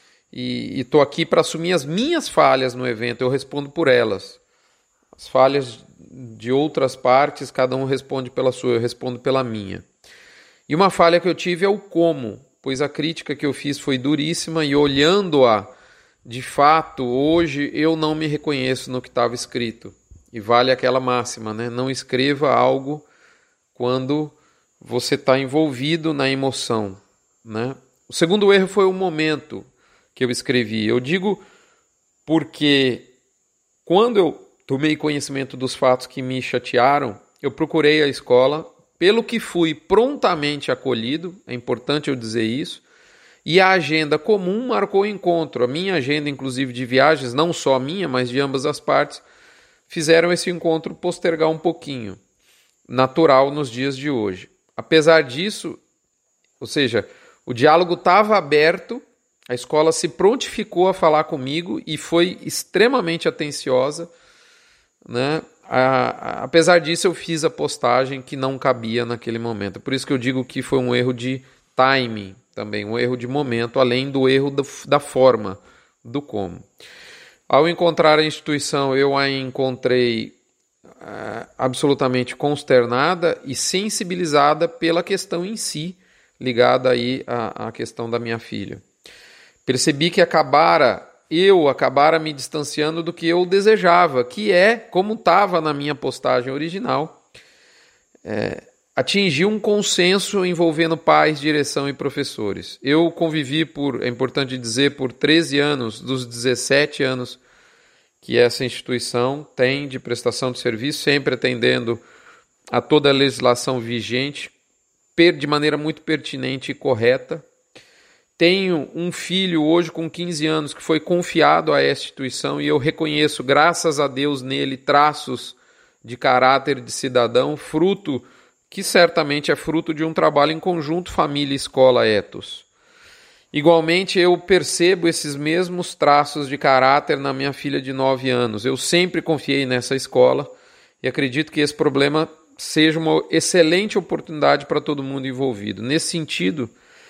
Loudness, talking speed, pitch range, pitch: -19 LUFS, 145 wpm, 130-170 Hz, 145 Hz